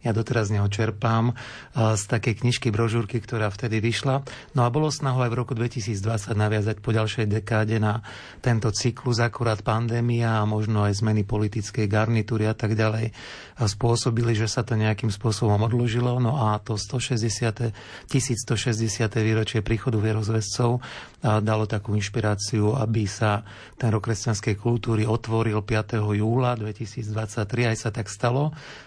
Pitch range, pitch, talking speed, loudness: 110-120 Hz, 115 Hz, 145 wpm, -25 LUFS